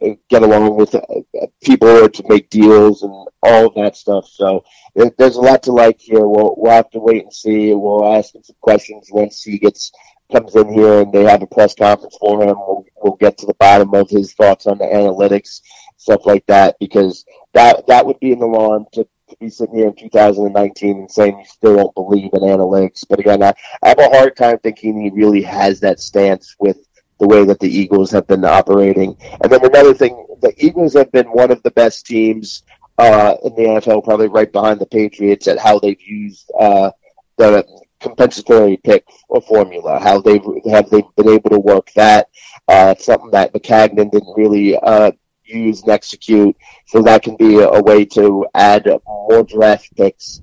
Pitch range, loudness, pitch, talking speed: 100-115 Hz, -11 LUFS, 105 Hz, 200 wpm